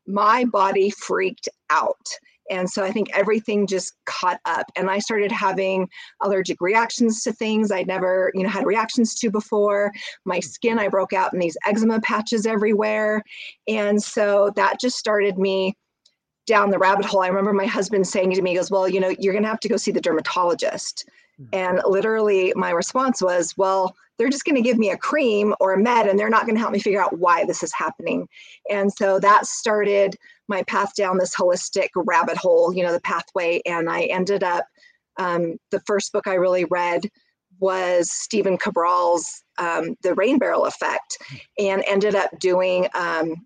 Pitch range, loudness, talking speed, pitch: 185-215 Hz, -21 LUFS, 190 wpm, 200 Hz